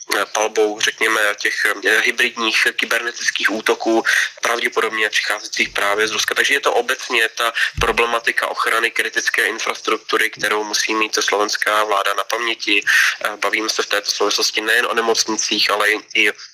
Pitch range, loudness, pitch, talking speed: 105-115 Hz, -17 LUFS, 110 Hz, 135 wpm